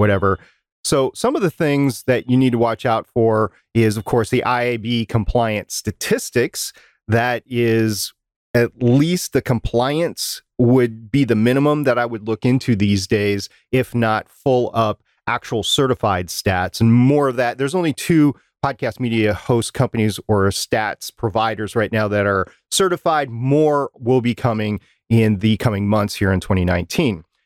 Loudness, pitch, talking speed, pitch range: -18 LUFS, 115 Hz, 160 wpm, 105-130 Hz